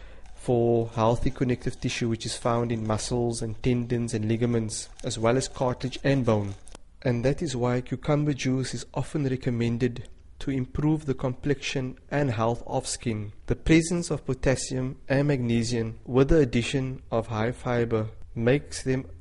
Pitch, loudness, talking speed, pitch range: 125 Hz, -27 LUFS, 155 wpm, 115-135 Hz